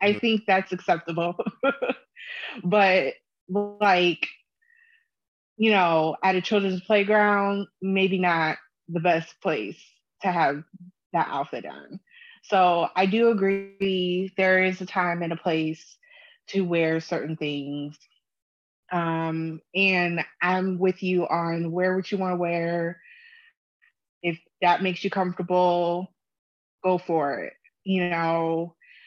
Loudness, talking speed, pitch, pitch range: -24 LUFS, 120 wpm, 185 Hz, 170-200 Hz